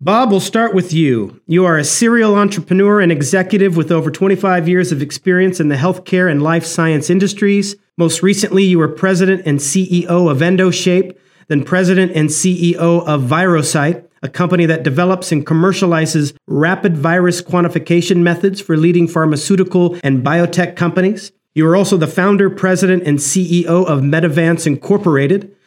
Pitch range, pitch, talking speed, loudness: 160-190 Hz, 175 Hz, 155 wpm, -13 LUFS